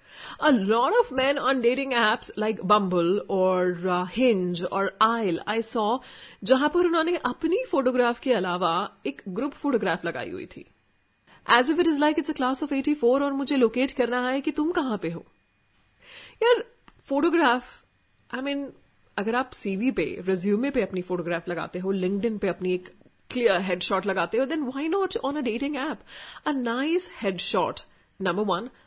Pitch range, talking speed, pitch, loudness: 195-280 Hz, 170 wpm, 240 Hz, -25 LUFS